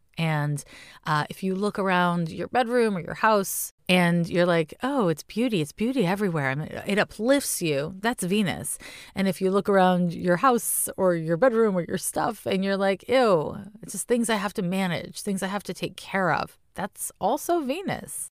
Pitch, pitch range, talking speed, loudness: 190 Hz, 175-220 Hz, 200 wpm, -25 LUFS